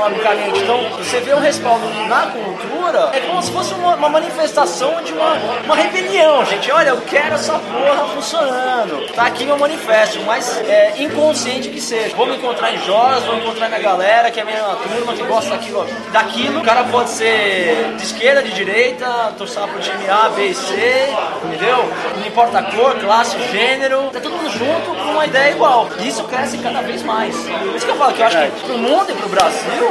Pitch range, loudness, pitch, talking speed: 225-300 Hz, -15 LUFS, 255 Hz, 205 wpm